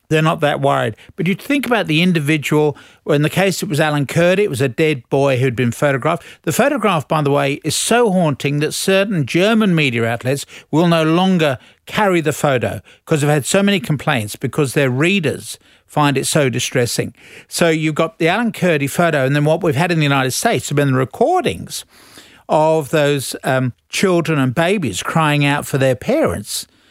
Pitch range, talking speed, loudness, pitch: 140-170 Hz, 200 wpm, -16 LUFS, 150 Hz